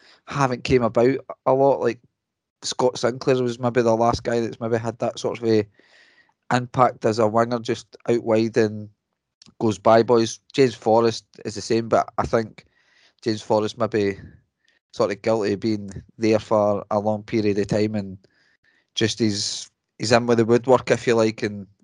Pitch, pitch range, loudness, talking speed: 115 Hz, 105-120 Hz, -22 LUFS, 185 wpm